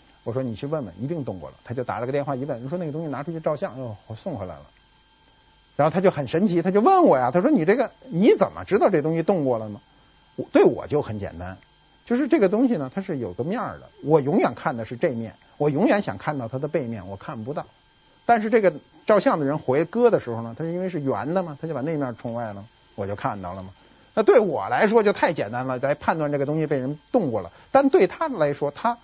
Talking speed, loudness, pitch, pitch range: 355 characters per minute, -23 LUFS, 145 Hz, 120-185 Hz